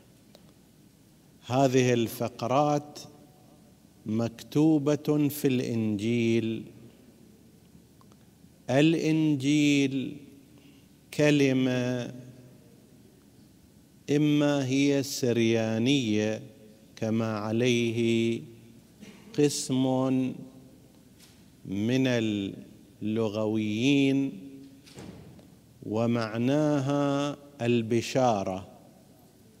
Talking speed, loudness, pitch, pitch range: 35 wpm, -27 LUFS, 125 Hz, 115-140 Hz